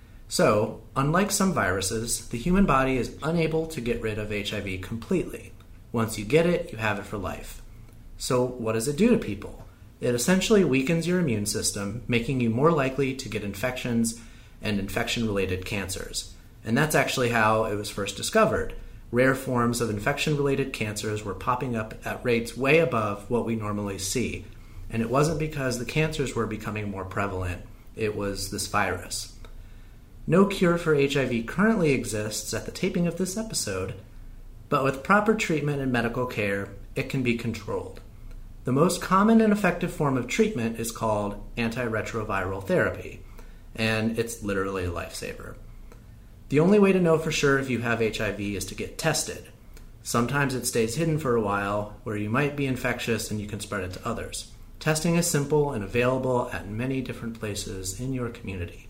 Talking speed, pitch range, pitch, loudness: 175 wpm, 105-135 Hz, 115 Hz, -26 LUFS